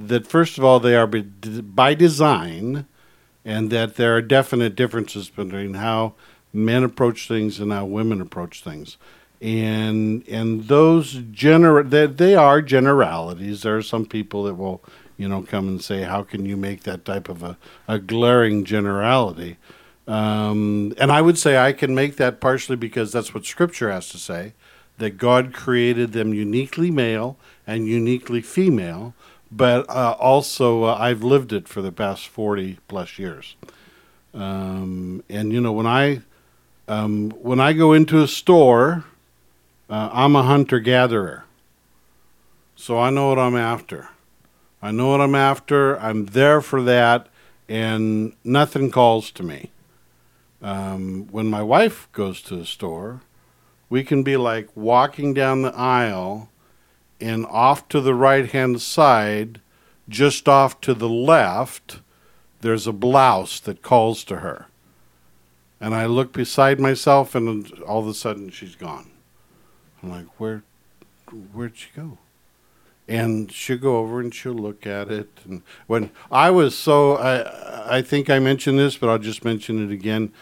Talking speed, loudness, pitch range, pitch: 155 wpm, -19 LUFS, 105-130 Hz, 115 Hz